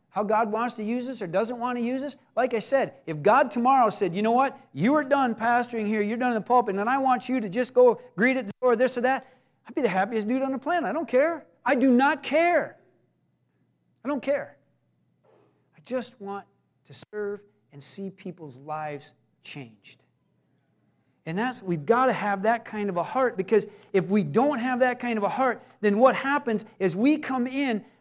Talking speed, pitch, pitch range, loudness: 220 wpm, 240 Hz, 200-260 Hz, -25 LUFS